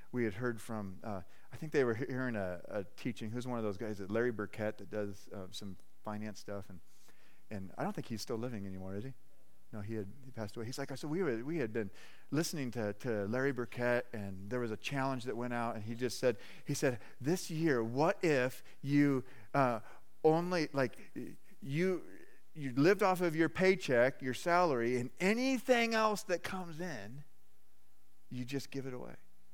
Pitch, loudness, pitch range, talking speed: 125 Hz, -36 LUFS, 105-145 Hz, 205 wpm